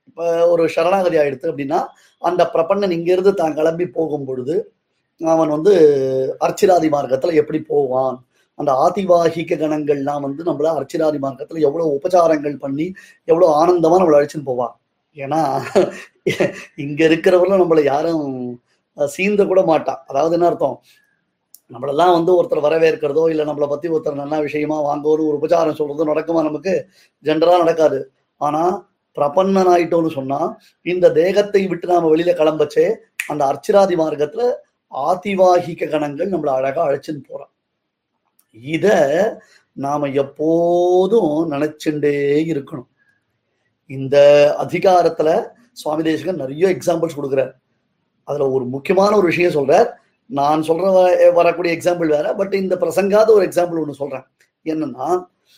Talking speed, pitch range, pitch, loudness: 120 wpm, 145-180 Hz, 160 Hz, -17 LUFS